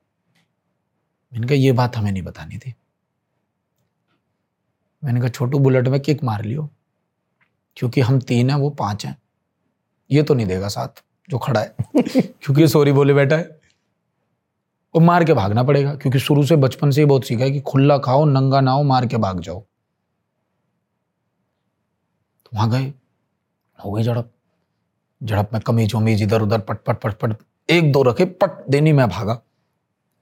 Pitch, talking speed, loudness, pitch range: 130 Hz, 150 wpm, -18 LUFS, 115-145 Hz